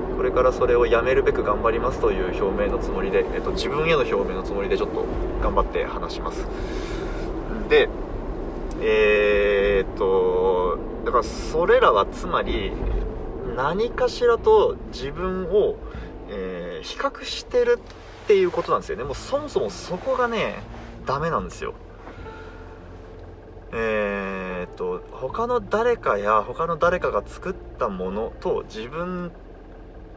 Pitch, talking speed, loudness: 230 Hz, 270 characters per minute, -23 LUFS